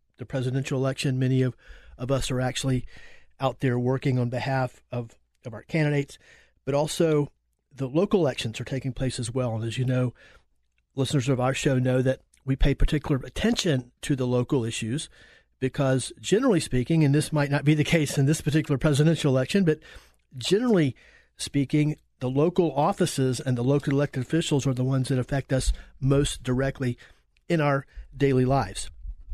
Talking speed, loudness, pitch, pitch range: 170 wpm, -26 LUFS, 135 Hz, 125-145 Hz